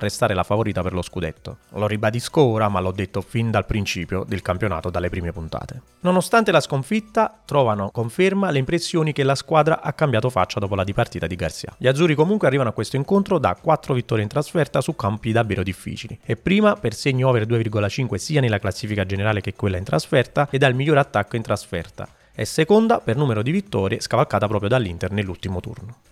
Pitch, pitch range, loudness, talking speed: 115 Hz, 100-145 Hz, -21 LUFS, 195 wpm